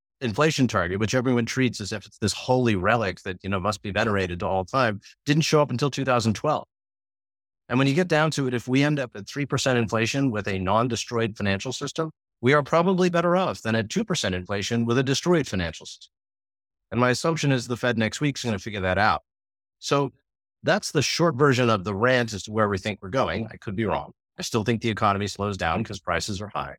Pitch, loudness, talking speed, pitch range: 115 Hz, -24 LUFS, 235 wpm, 100-135 Hz